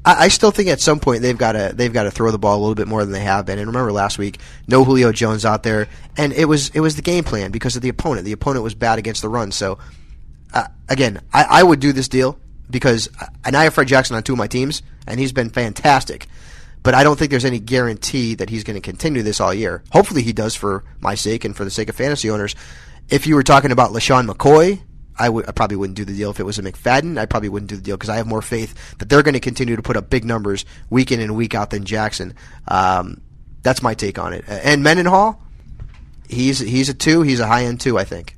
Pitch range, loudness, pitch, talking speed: 105-130 Hz, -17 LUFS, 115 Hz, 265 wpm